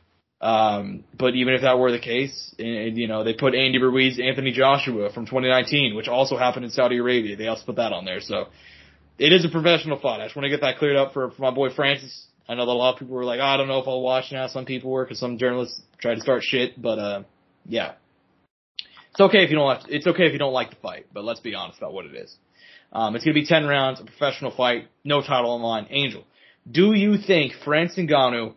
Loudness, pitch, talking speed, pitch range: -22 LUFS, 130 Hz, 255 wpm, 120-140 Hz